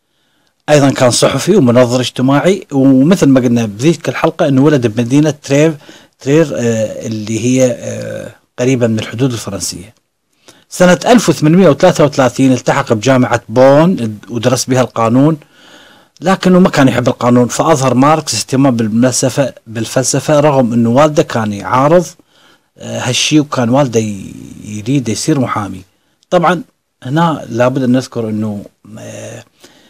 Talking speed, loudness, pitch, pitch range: 110 wpm, -11 LUFS, 130 Hz, 120-150 Hz